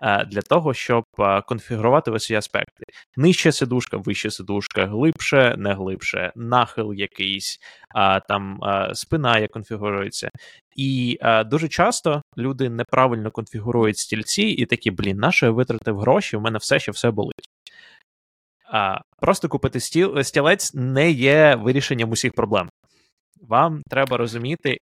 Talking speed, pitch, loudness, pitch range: 135 wpm, 120 Hz, -20 LUFS, 105-135 Hz